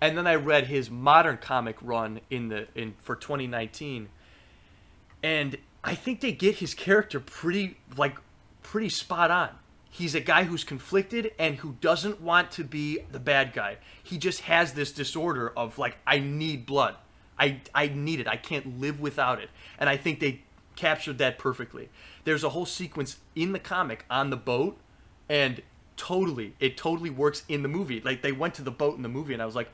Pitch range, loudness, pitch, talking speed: 130-170 Hz, -28 LUFS, 145 Hz, 195 wpm